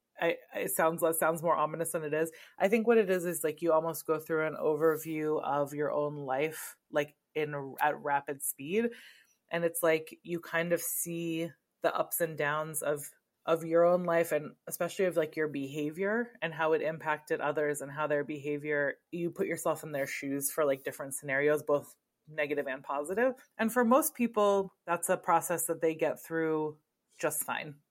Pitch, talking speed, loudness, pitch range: 160 Hz, 190 wpm, -32 LUFS, 150-170 Hz